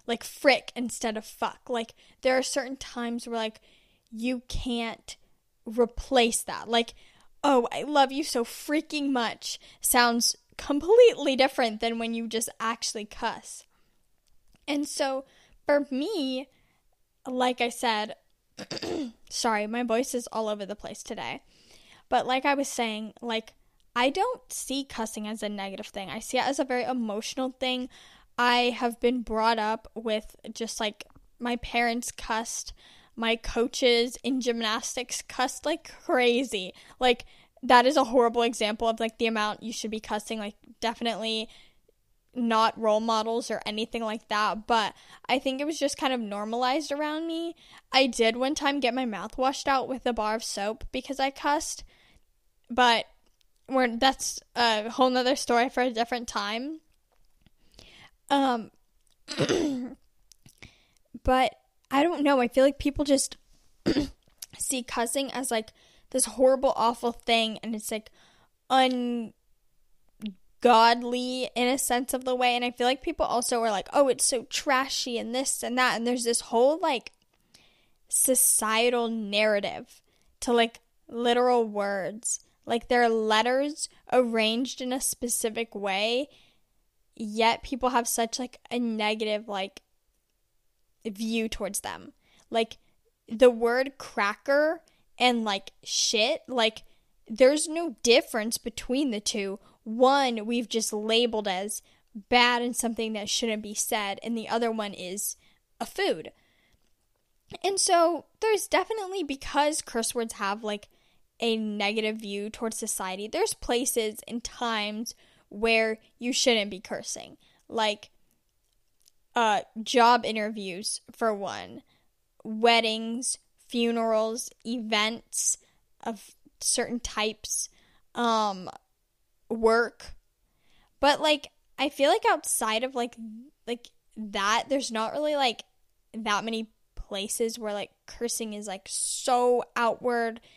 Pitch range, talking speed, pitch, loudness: 225-260 Hz, 135 wpm, 235 Hz, -27 LUFS